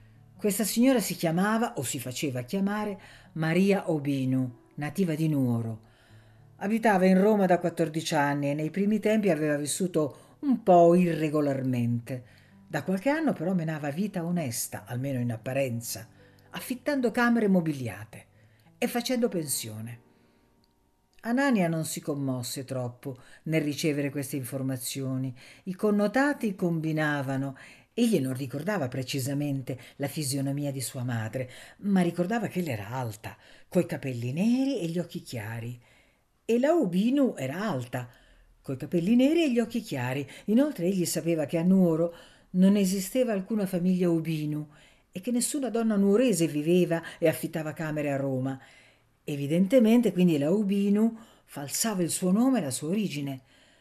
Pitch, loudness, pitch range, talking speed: 160 Hz, -27 LUFS, 135-195 Hz, 140 wpm